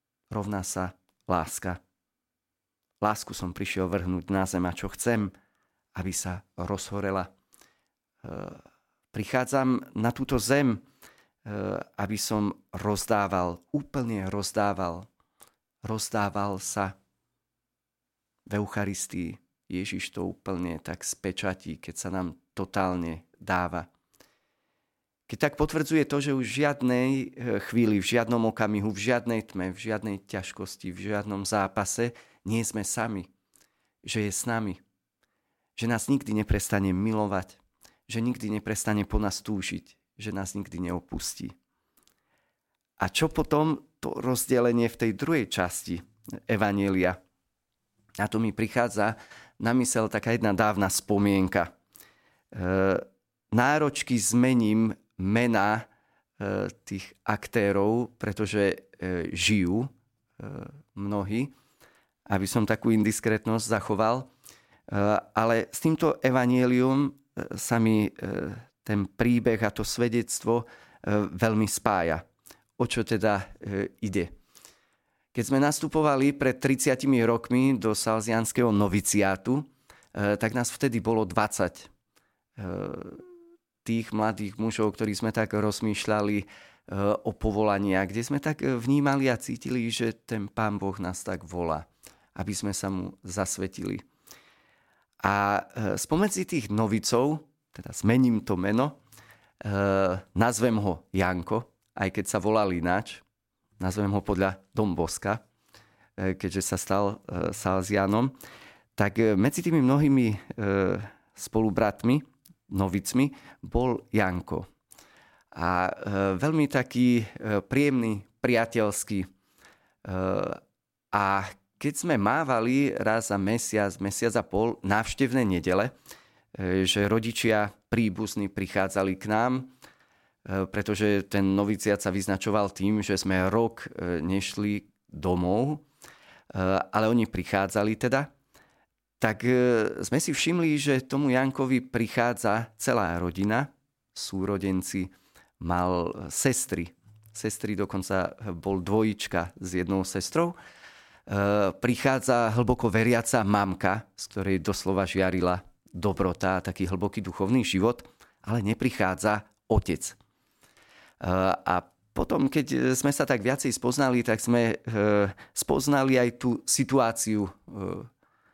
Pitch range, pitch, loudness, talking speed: 95-120 Hz, 105 Hz, -27 LUFS, 105 wpm